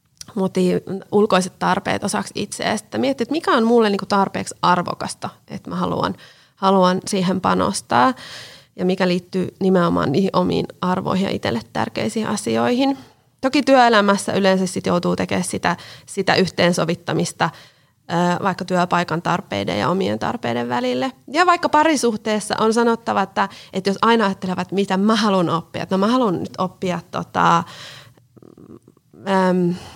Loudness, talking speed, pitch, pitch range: -19 LUFS, 135 wpm, 190 Hz, 175-215 Hz